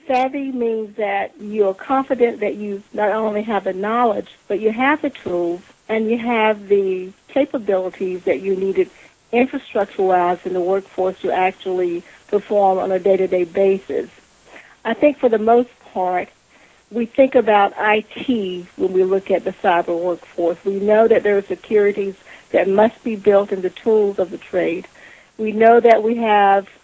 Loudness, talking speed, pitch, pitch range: -18 LUFS, 170 wpm, 205 Hz, 190-225 Hz